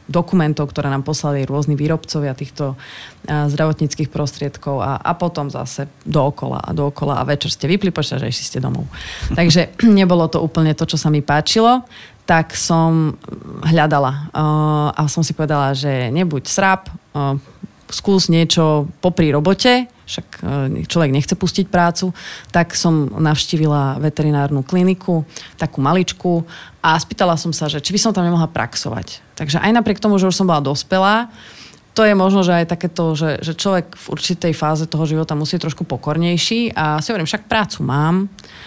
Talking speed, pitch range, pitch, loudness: 160 wpm, 145-180 Hz, 160 Hz, -17 LUFS